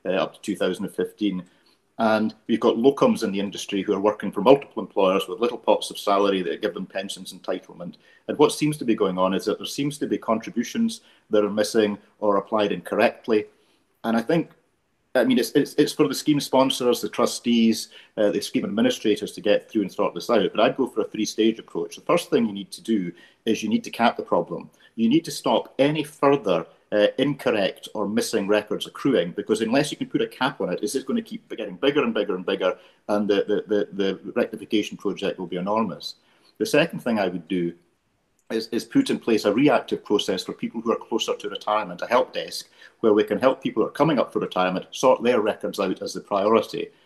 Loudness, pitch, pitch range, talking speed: -23 LUFS, 115 Hz, 105-150 Hz, 225 wpm